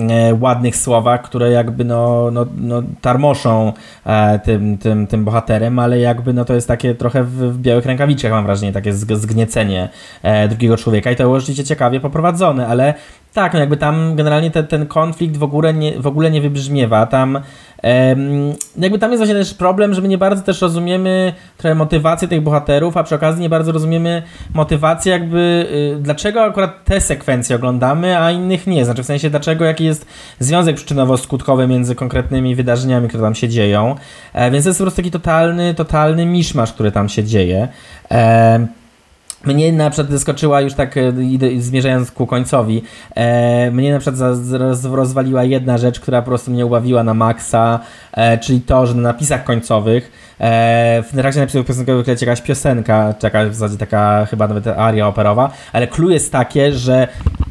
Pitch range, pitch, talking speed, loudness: 115-155 Hz, 130 Hz, 170 wpm, -14 LUFS